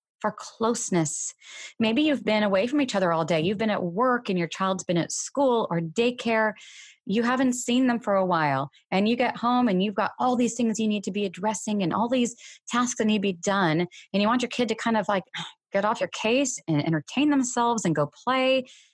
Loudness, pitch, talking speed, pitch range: -25 LUFS, 220 Hz, 230 wpm, 190-245 Hz